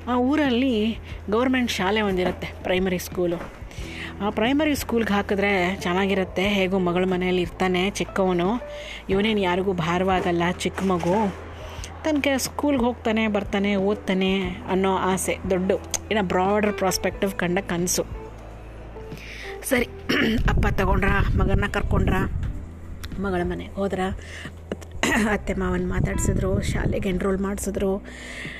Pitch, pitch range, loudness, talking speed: 190 Hz, 180-210 Hz, -23 LUFS, 105 wpm